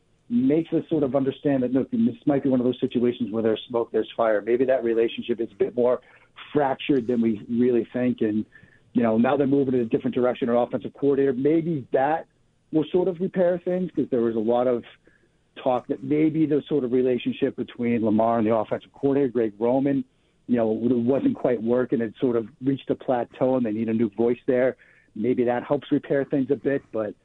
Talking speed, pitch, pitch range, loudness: 220 wpm, 125 Hz, 120-140 Hz, -24 LUFS